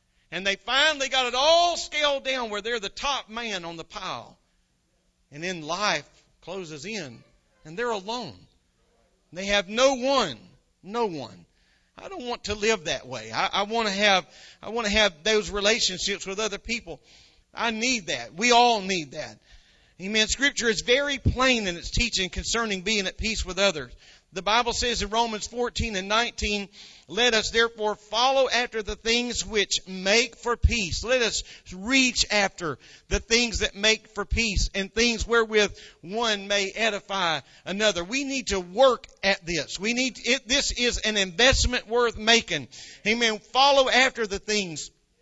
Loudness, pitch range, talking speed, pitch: -24 LUFS, 195-240 Hz, 170 wpm, 215 Hz